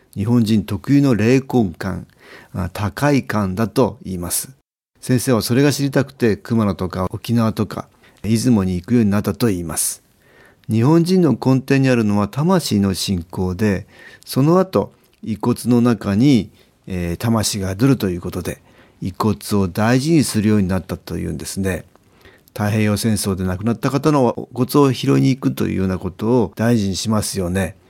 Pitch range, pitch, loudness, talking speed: 95-125 Hz, 110 Hz, -18 LUFS, 315 characters per minute